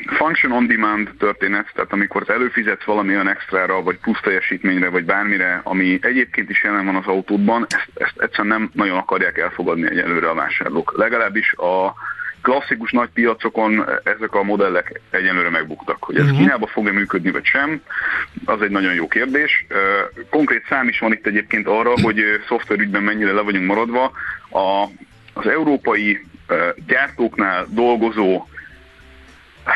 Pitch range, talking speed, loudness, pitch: 95-110 Hz, 145 wpm, -18 LUFS, 100 Hz